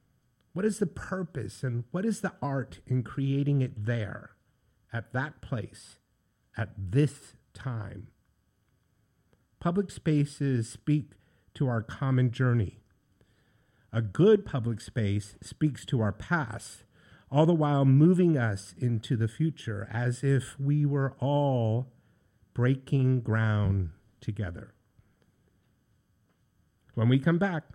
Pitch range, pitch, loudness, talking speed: 110-140 Hz, 125 Hz, -29 LUFS, 115 wpm